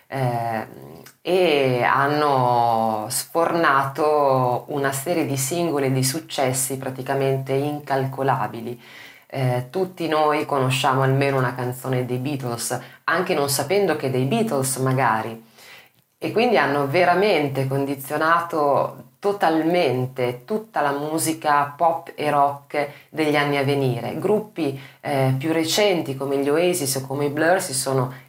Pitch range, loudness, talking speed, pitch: 130-155 Hz, -21 LUFS, 125 wpm, 140 Hz